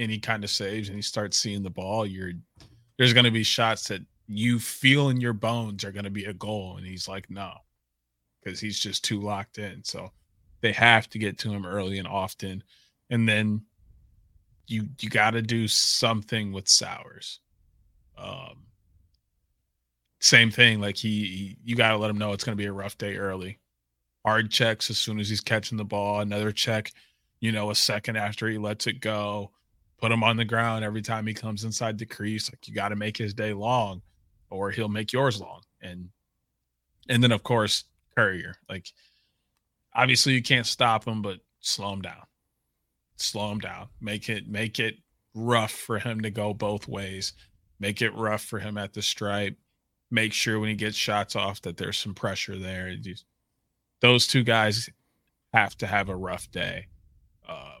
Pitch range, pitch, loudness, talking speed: 100-115 Hz, 105 Hz, -25 LUFS, 185 wpm